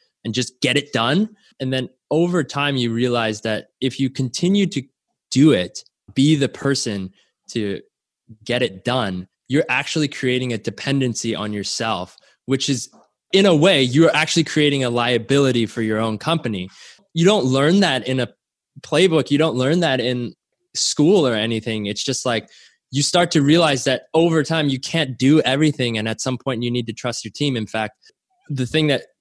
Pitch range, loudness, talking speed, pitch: 115-155 Hz, -19 LUFS, 185 wpm, 130 Hz